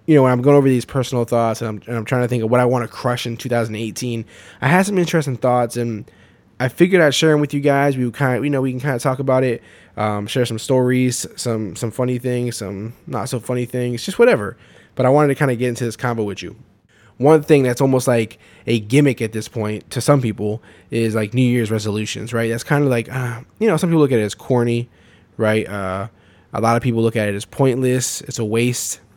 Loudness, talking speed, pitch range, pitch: -18 LUFS, 255 wpm, 110-130 Hz, 120 Hz